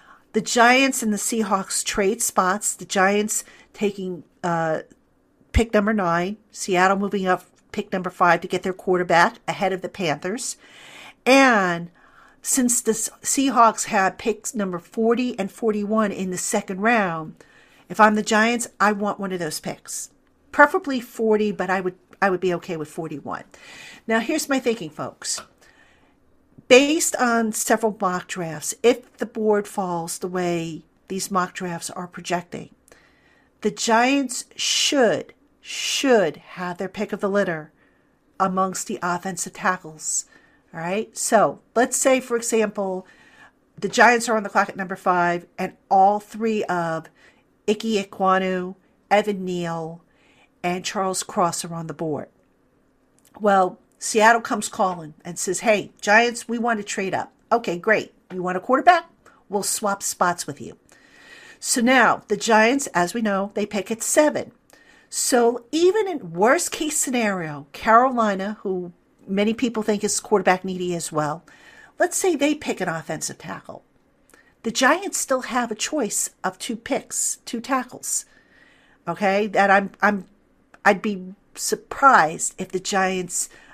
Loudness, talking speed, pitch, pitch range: -21 LUFS, 150 wpm, 205 Hz, 185-235 Hz